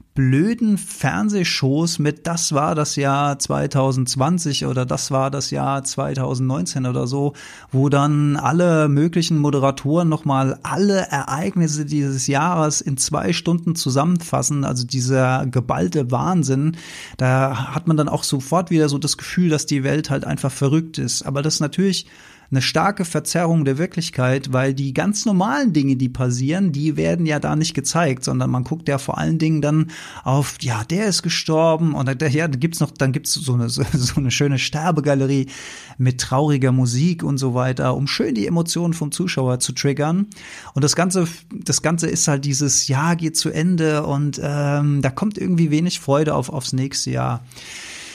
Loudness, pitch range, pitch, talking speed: -19 LUFS, 135-165 Hz, 145 Hz, 170 wpm